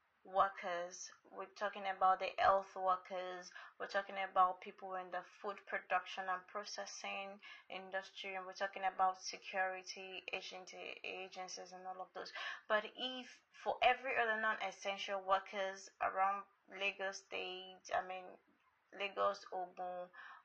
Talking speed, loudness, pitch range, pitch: 130 wpm, -41 LUFS, 185-200 Hz, 190 Hz